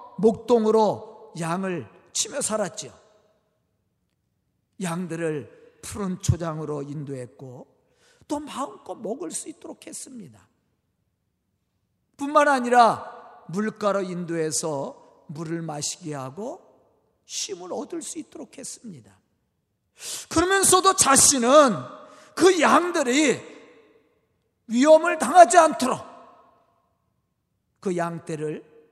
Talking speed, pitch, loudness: 195 characters per minute, 220 Hz, -22 LUFS